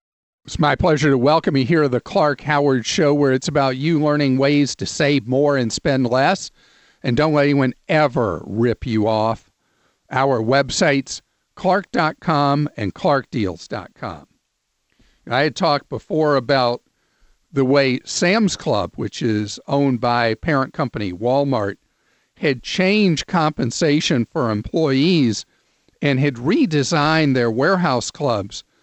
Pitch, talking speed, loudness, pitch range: 140 Hz, 135 wpm, -18 LUFS, 125-155 Hz